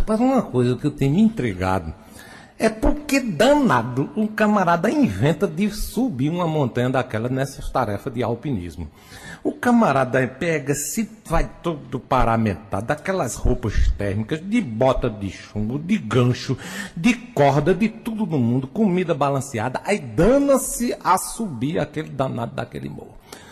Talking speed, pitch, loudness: 140 wpm, 150 Hz, -21 LUFS